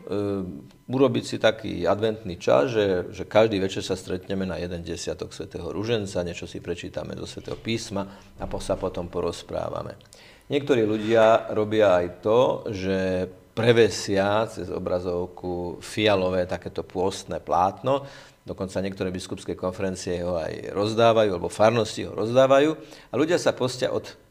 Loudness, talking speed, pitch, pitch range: -25 LUFS, 140 wpm, 95 Hz, 90-110 Hz